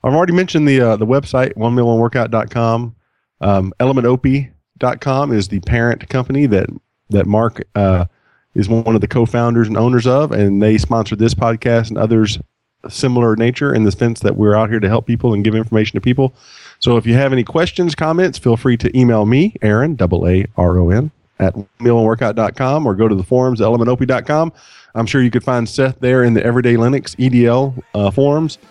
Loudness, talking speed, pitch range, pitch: -14 LUFS, 185 wpm, 110-130 Hz, 120 Hz